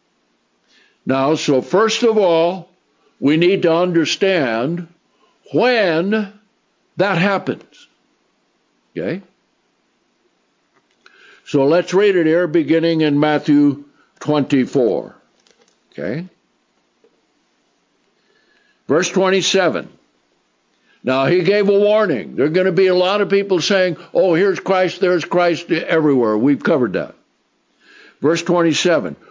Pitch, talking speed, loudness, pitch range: 175 Hz, 105 wpm, -16 LUFS, 150-190 Hz